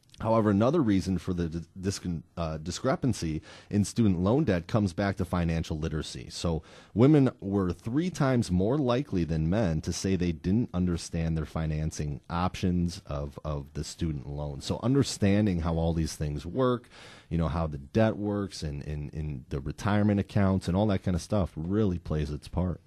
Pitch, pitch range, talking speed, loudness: 90 Hz, 80-105 Hz, 180 wpm, -29 LUFS